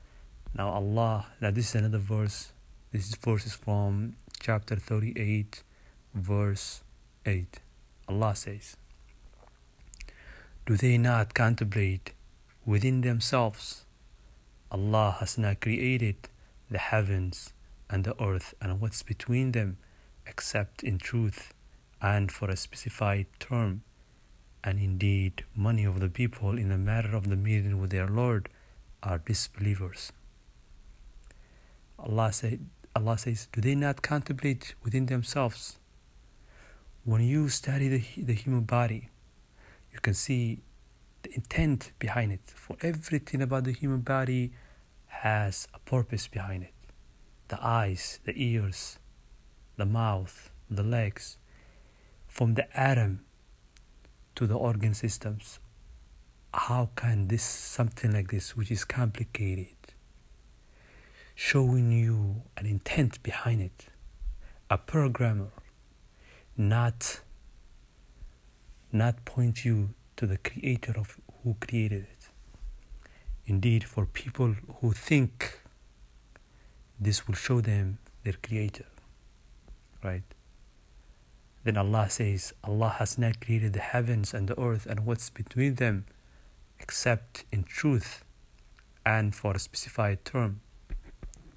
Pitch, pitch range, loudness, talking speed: 105 Hz, 95-120 Hz, -30 LUFS, 115 wpm